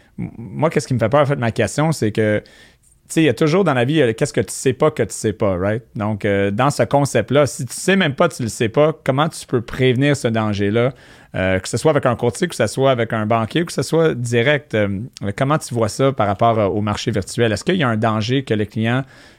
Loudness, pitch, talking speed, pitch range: -18 LUFS, 120 Hz, 280 wpm, 110-145 Hz